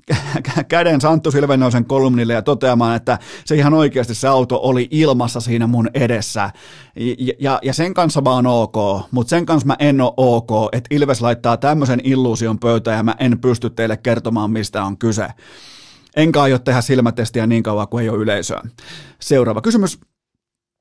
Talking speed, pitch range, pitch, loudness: 165 wpm, 115-140 Hz, 125 Hz, -16 LUFS